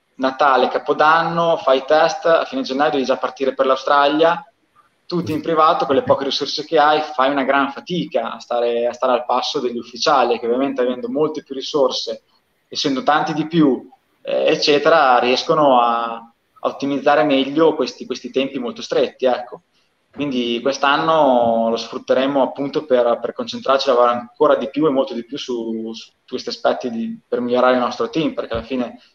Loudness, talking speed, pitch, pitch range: -18 LUFS, 175 wpm, 135 Hz, 125-155 Hz